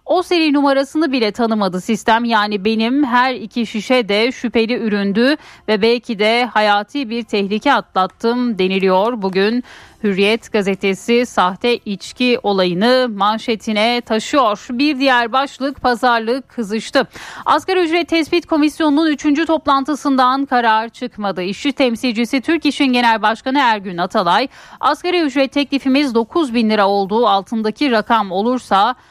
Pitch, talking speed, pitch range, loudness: 240 Hz, 125 wpm, 215-275 Hz, -16 LUFS